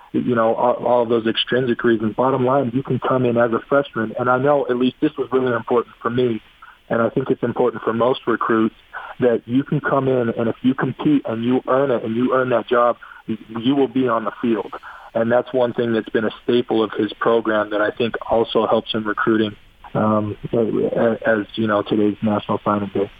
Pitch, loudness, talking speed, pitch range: 120 Hz, -19 LUFS, 220 wpm, 110-130 Hz